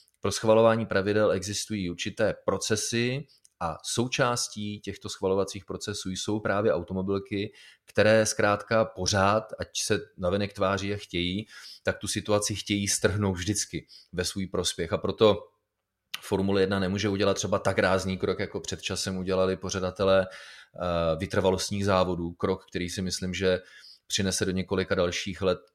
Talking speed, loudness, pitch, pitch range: 135 wpm, -27 LUFS, 100 Hz, 95-105 Hz